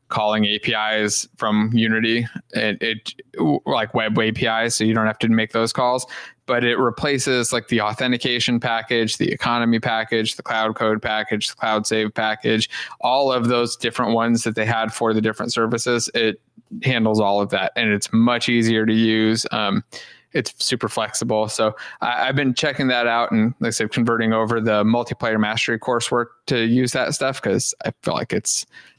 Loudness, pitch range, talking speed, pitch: -20 LUFS, 110-120 Hz, 185 wpm, 115 Hz